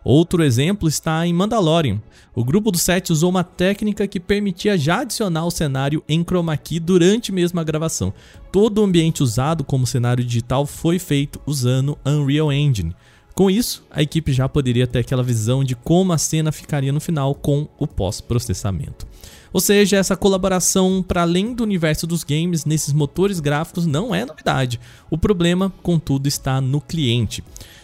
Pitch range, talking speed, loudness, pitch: 135-180 Hz, 170 wpm, -19 LUFS, 160 Hz